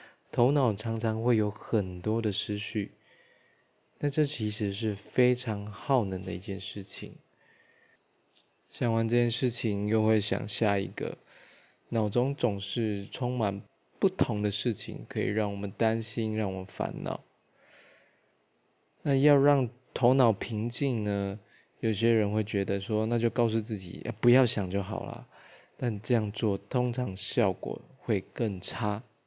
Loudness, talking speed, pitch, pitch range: -29 LUFS, 200 characters per minute, 110 Hz, 105-120 Hz